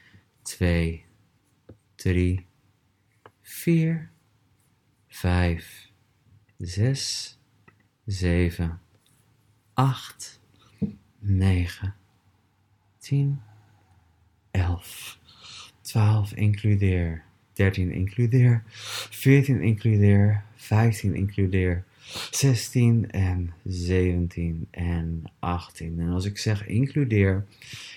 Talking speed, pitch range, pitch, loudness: 60 wpm, 90-115 Hz, 105 Hz, -25 LUFS